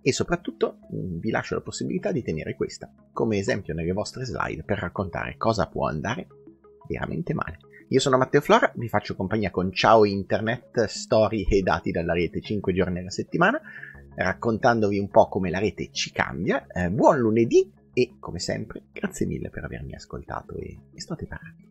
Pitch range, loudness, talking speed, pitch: 90-120 Hz, -25 LUFS, 175 wpm, 105 Hz